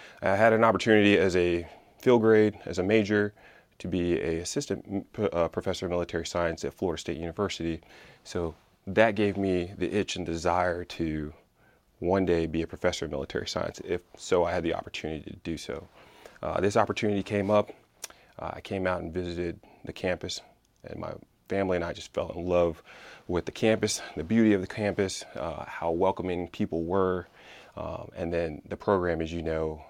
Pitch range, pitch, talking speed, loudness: 85-100 Hz, 90 Hz, 190 wpm, -28 LUFS